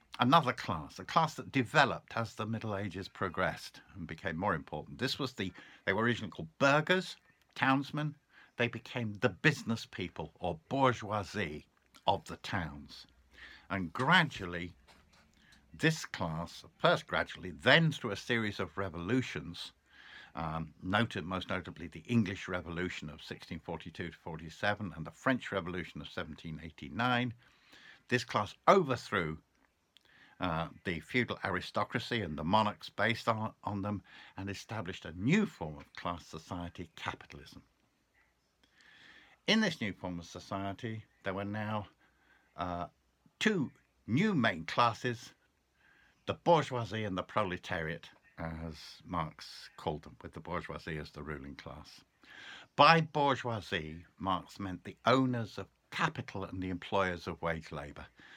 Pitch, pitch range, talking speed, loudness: 100 Hz, 85-120 Hz, 135 wpm, -34 LUFS